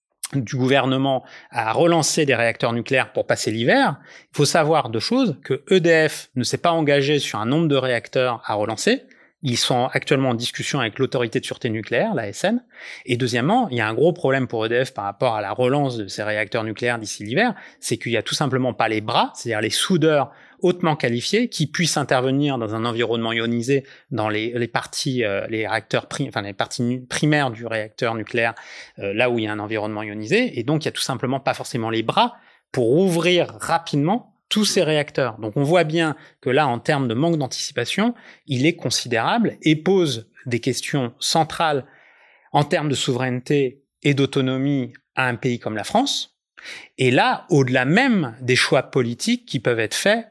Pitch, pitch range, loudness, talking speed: 130 Hz, 120-155 Hz, -21 LUFS, 200 wpm